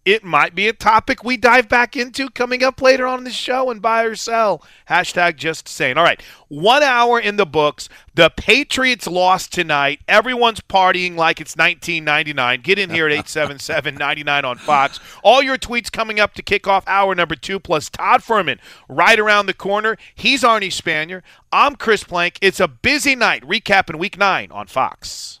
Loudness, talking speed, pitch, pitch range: -16 LUFS, 185 wpm, 200 Hz, 170-240 Hz